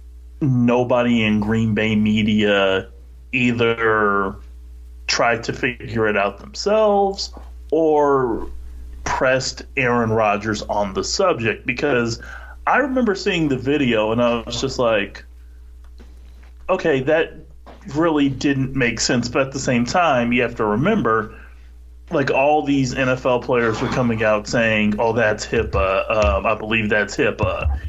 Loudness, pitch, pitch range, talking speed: -19 LUFS, 115 Hz, 75-130 Hz, 135 wpm